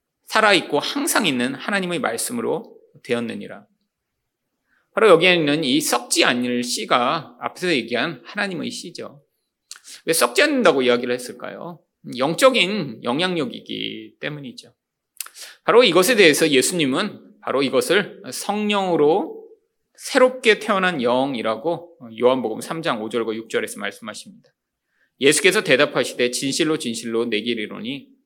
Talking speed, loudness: 300 characters per minute, -19 LUFS